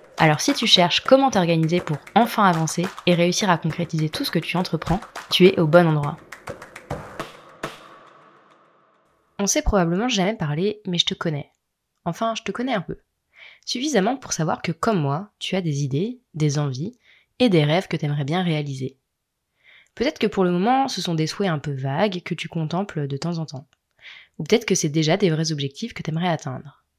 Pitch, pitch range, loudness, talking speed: 170 Hz, 155-195 Hz, -21 LUFS, 200 wpm